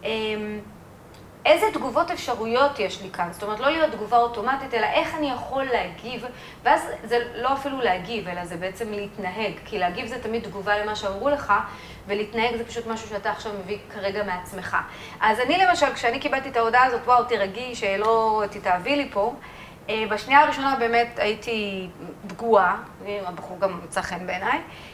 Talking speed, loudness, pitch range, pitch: 160 wpm, -24 LUFS, 200-250 Hz, 220 Hz